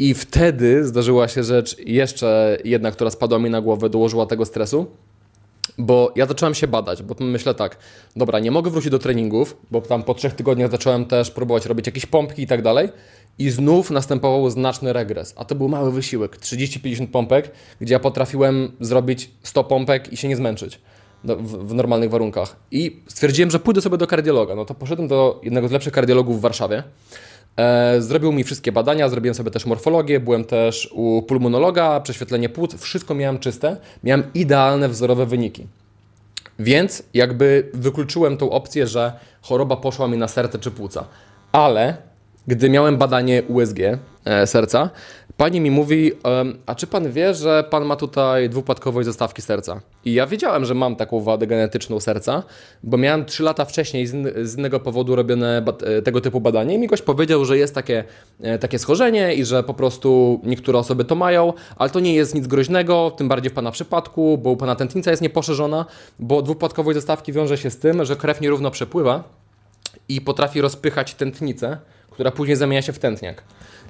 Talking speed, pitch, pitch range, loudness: 175 wpm, 130 Hz, 115-145 Hz, -19 LUFS